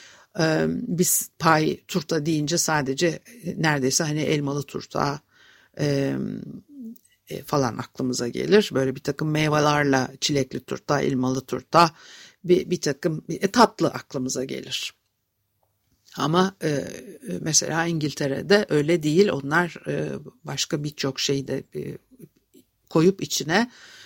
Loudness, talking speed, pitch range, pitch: -23 LUFS, 110 wpm, 135-175 Hz, 150 Hz